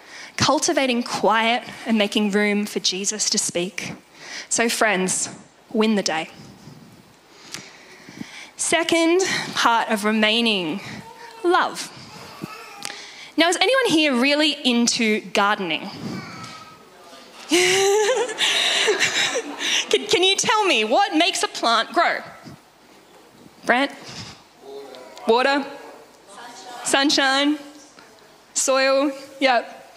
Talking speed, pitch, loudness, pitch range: 80 wpm, 265 Hz, -19 LUFS, 215-335 Hz